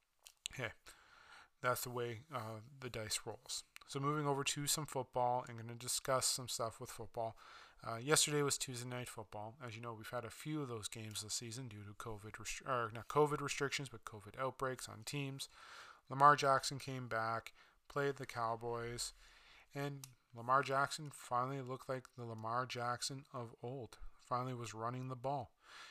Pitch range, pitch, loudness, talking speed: 115-140 Hz, 125 Hz, -40 LUFS, 180 wpm